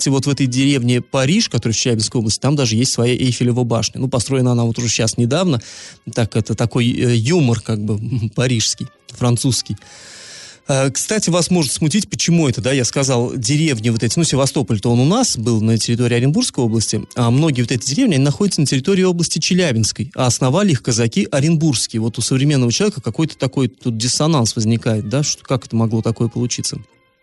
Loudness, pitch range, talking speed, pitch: -16 LUFS, 115-140 Hz, 190 wpm, 125 Hz